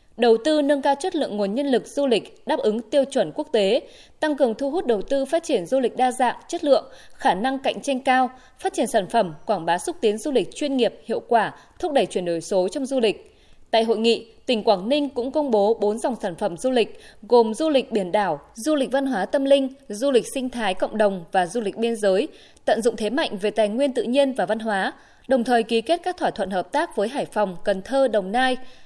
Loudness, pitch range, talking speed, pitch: -22 LUFS, 215-280 Hz, 255 wpm, 245 Hz